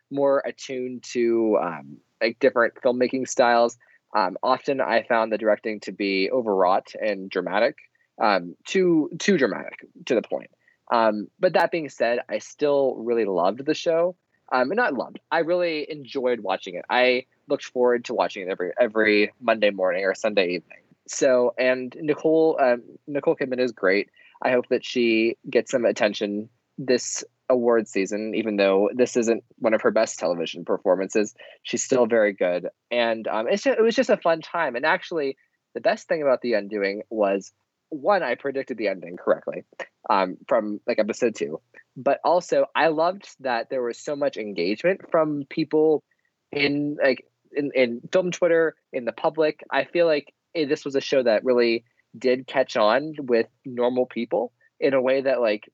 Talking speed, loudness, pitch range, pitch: 175 wpm, -23 LUFS, 115-150 Hz, 125 Hz